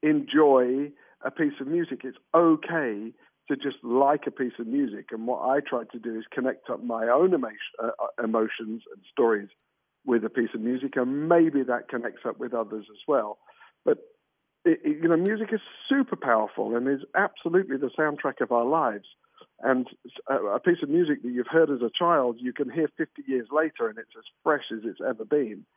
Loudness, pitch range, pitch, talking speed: -26 LUFS, 125-170 Hz, 140 Hz, 200 wpm